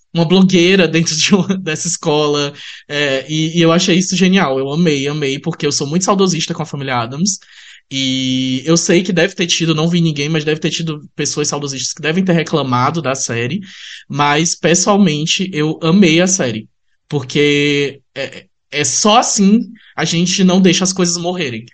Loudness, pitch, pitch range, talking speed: -14 LUFS, 160 Hz, 145-180 Hz, 180 wpm